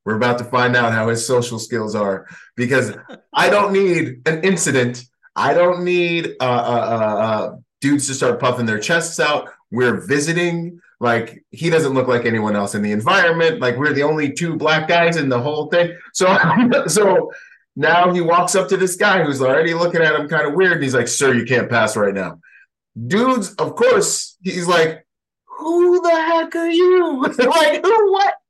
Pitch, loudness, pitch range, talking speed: 160 Hz, -16 LUFS, 125-190 Hz, 190 wpm